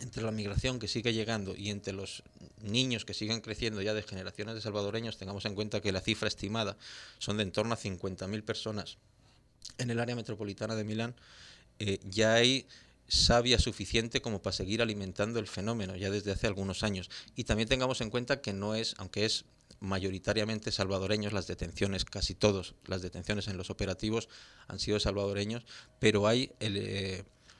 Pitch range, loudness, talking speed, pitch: 100-115 Hz, -33 LUFS, 180 wpm, 105 Hz